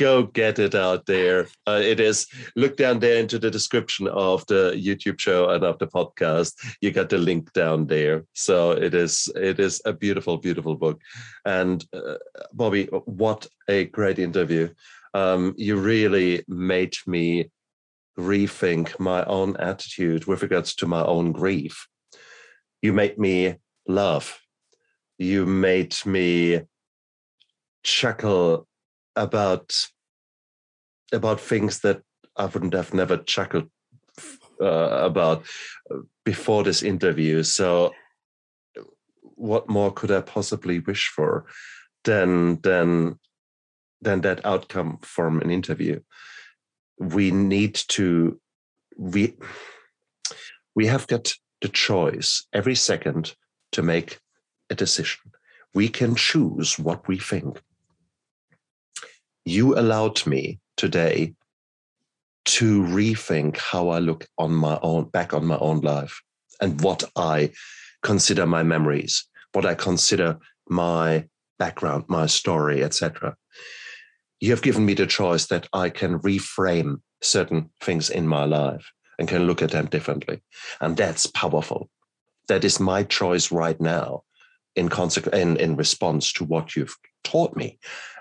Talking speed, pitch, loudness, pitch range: 130 wpm, 90 Hz, -23 LUFS, 80-100 Hz